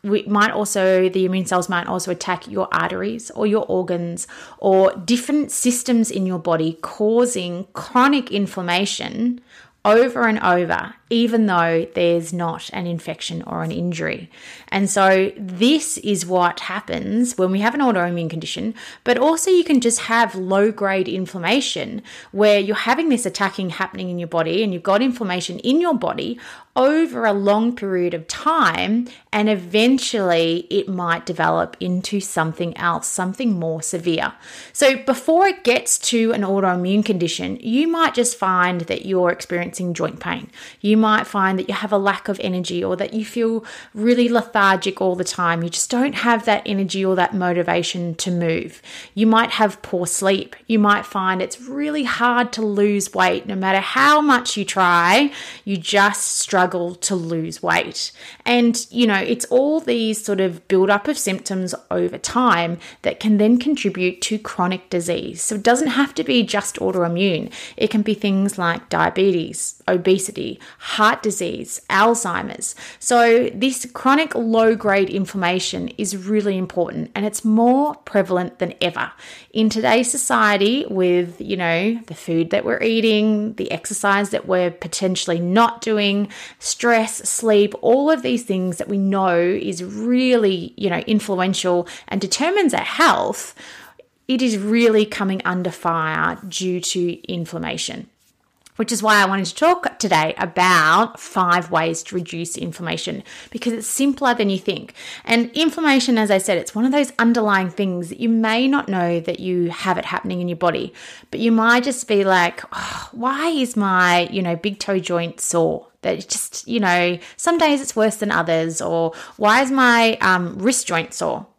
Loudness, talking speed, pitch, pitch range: -19 LUFS, 165 wpm, 200 Hz, 180-235 Hz